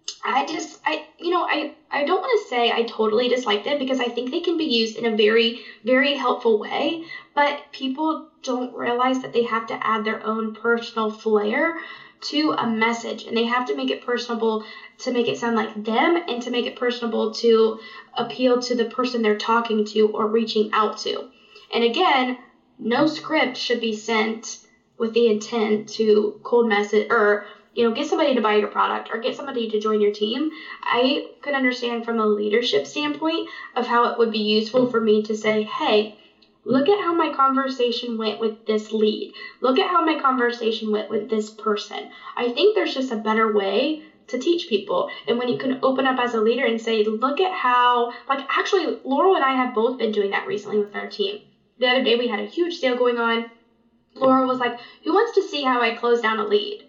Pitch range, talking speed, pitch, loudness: 220-265 Hz, 210 wpm, 235 Hz, -22 LUFS